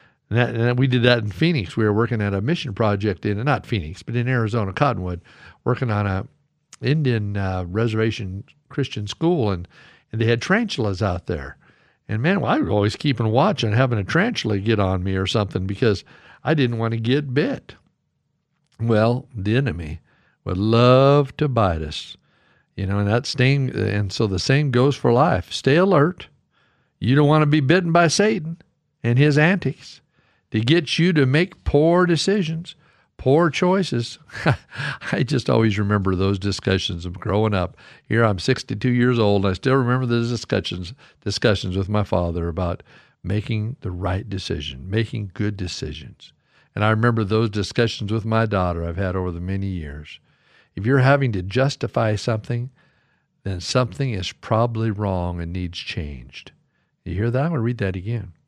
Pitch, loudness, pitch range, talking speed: 115 Hz, -21 LUFS, 100-135 Hz, 175 wpm